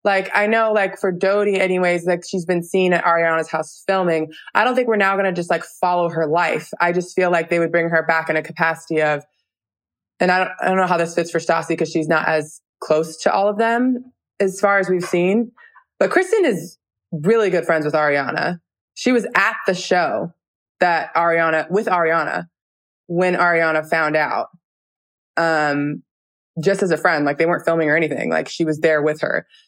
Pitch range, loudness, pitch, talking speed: 160-195 Hz, -18 LUFS, 170 Hz, 210 wpm